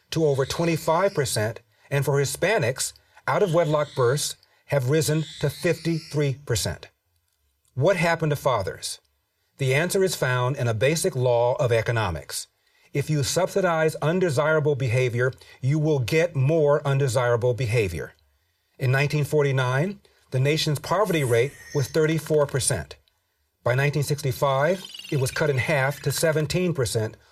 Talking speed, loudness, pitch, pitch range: 125 wpm, -24 LUFS, 140 Hz, 125-155 Hz